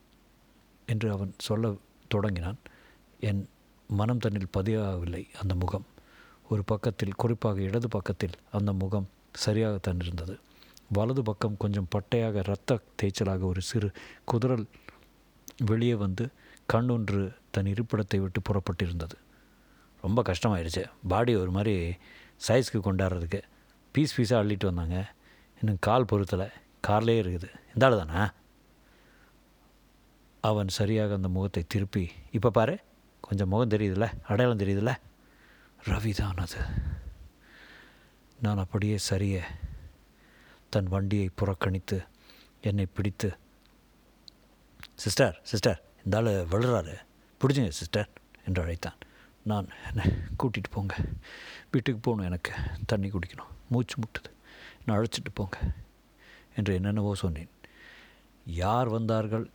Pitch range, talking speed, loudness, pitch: 95-110 Hz, 105 wpm, -30 LUFS, 100 Hz